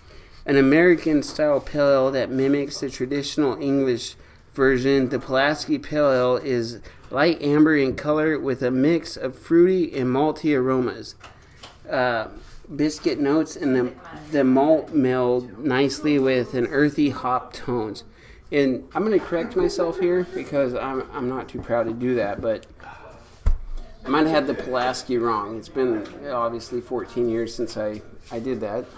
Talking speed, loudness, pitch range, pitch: 155 wpm, -22 LUFS, 125-150 Hz, 130 Hz